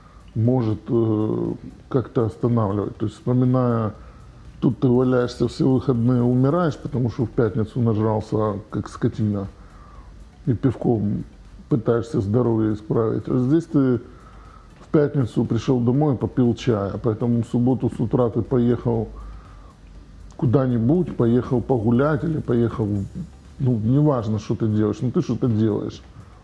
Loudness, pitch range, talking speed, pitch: -21 LUFS, 110-125 Hz, 125 wpm, 120 Hz